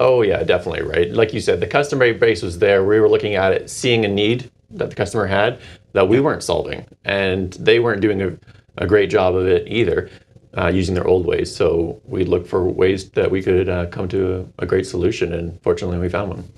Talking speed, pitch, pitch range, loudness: 230 wpm, 100 Hz, 90-135 Hz, -18 LUFS